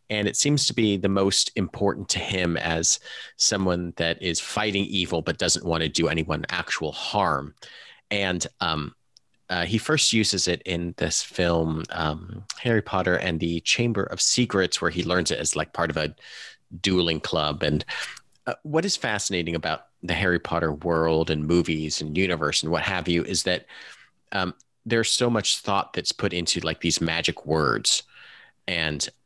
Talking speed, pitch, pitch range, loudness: 175 wpm, 90 Hz, 85-100 Hz, -24 LUFS